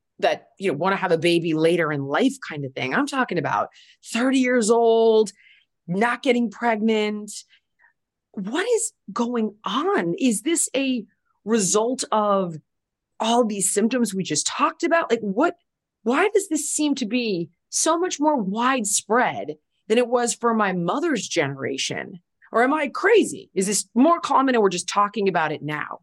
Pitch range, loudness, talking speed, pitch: 190-260 Hz, -22 LUFS, 170 wpm, 230 Hz